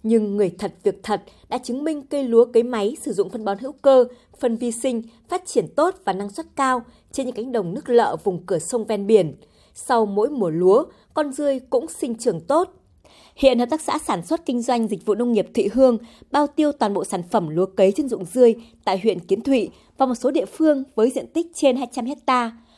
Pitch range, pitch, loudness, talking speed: 215-275 Hz, 245 Hz, -21 LUFS, 235 wpm